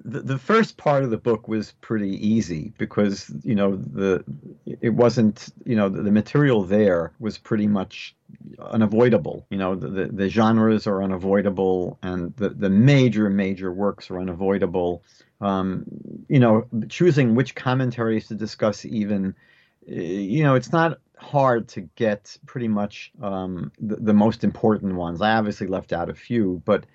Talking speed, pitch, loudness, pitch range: 165 wpm, 105 Hz, -22 LUFS, 95-115 Hz